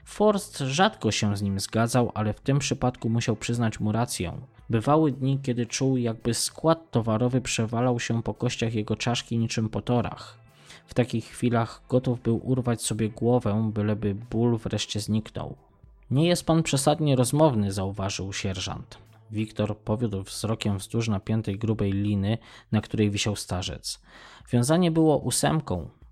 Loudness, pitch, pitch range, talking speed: -26 LUFS, 115 Hz, 105-125 Hz, 140 wpm